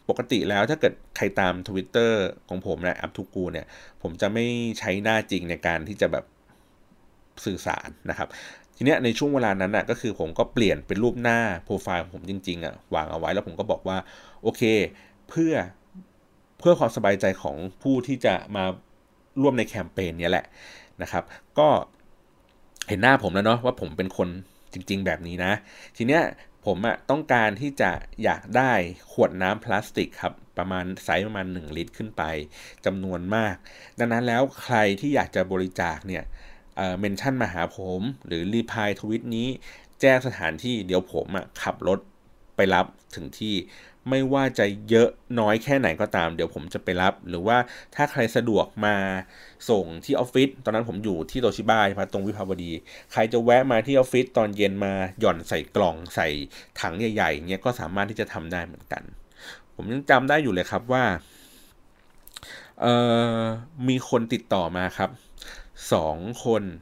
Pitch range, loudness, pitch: 95-120 Hz, -25 LUFS, 105 Hz